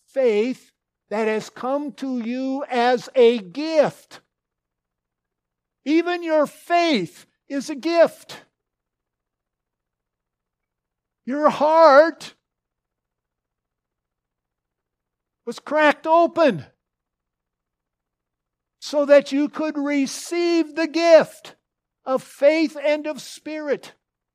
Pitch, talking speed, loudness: 235 Hz, 80 wpm, -20 LUFS